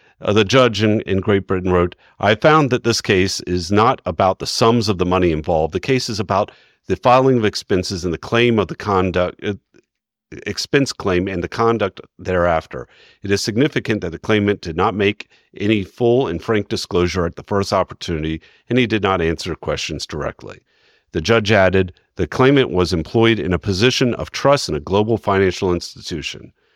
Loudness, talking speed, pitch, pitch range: -18 LUFS, 190 wpm, 100 Hz, 90-115 Hz